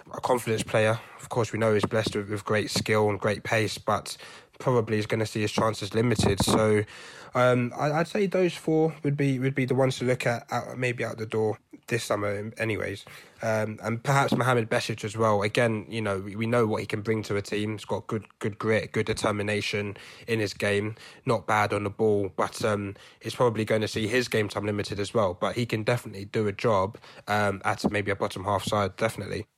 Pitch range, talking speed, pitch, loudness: 105-120 Hz, 220 wpm, 110 Hz, -27 LUFS